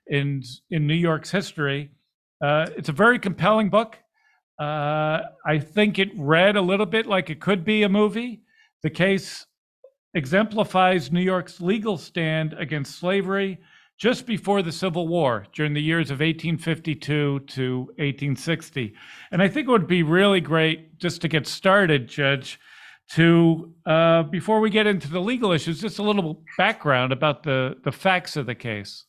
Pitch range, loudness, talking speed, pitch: 150-200 Hz, -22 LUFS, 165 wpm, 170 Hz